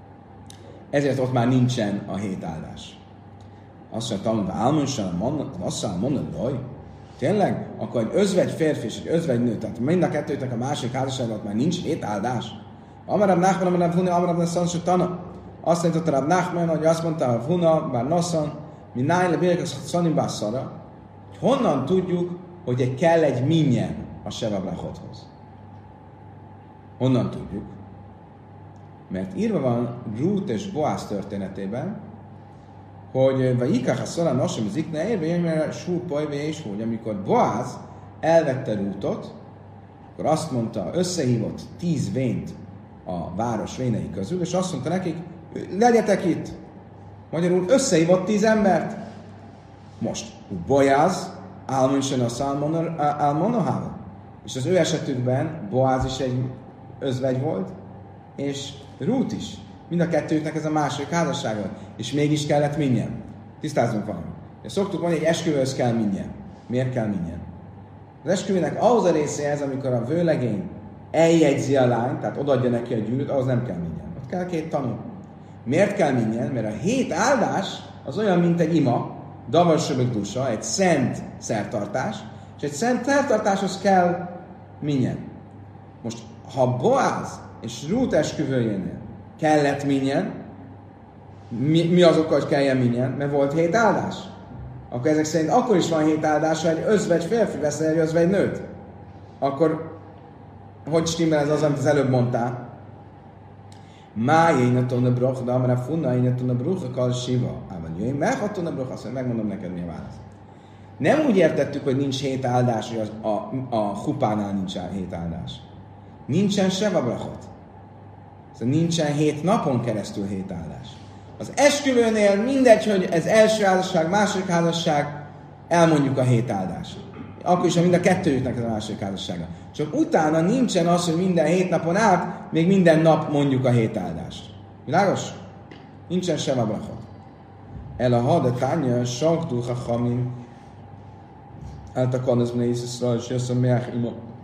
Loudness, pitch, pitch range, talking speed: -23 LUFS, 135 Hz, 110-165 Hz, 135 wpm